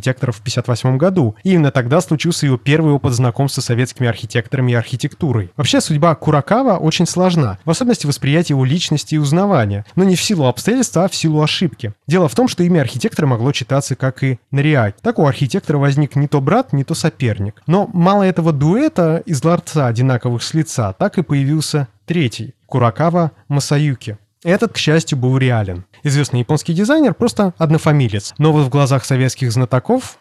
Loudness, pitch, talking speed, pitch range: -15 LUFS, 145 Hz, 175 wpm, 130-170 Hz